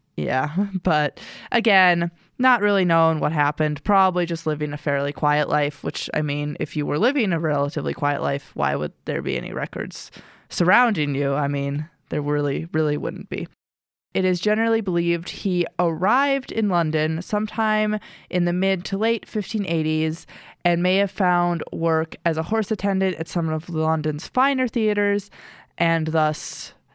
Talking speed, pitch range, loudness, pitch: 165 wpm, 150-200 Hz, -22 LUFS, 170 Hz